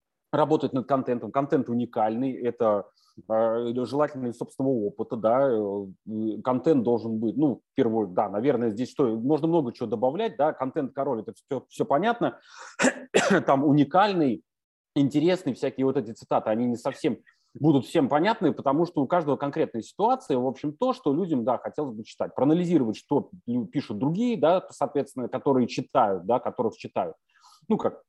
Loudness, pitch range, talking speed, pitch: -26 LUFS, 120-155 Hz, 160 wpm, 135 Hz